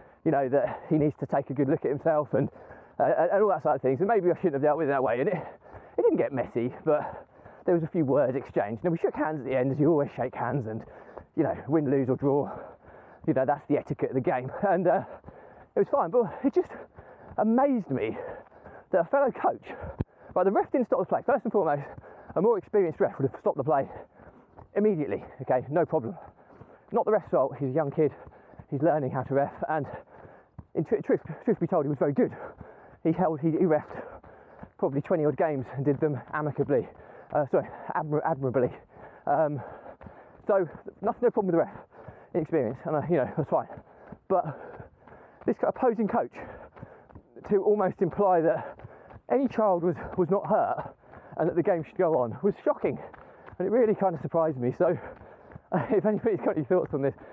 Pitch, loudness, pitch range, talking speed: 160 Hz, -27 LUFS, 140-200 Hz, 210 wpm